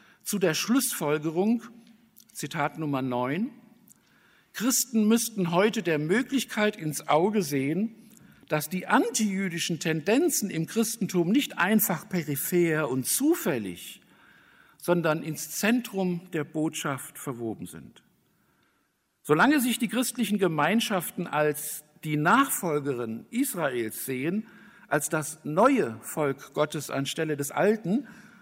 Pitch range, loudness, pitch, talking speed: 150-225 Hz, -27 LUFS, 185 Hz, 105 wpm